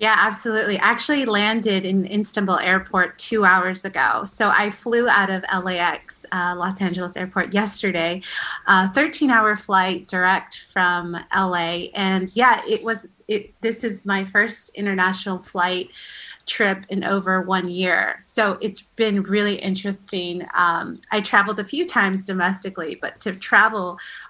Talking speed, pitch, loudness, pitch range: 145 wpm, 195 Hz, -20 LUFS, 185-215 Hz